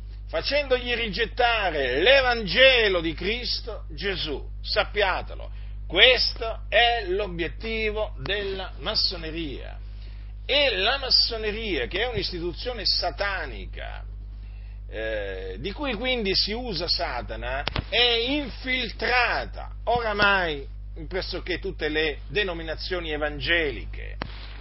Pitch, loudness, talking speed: 190 Hz, -24 LUFS, 85 wpm